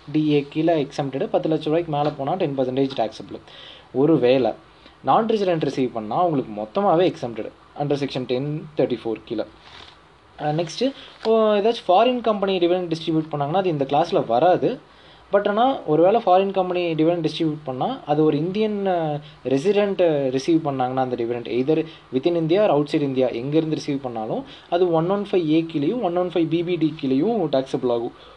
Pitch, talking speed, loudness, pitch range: 155 Hz, 160 wpm, -21 LUFS, 135-180 Hz